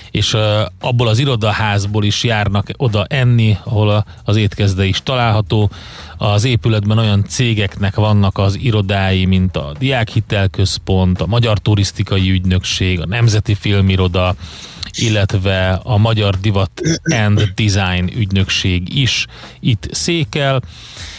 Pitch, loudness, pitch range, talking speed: 105 Hz, -15 LUFS, 95-115 Hz, 115 wpm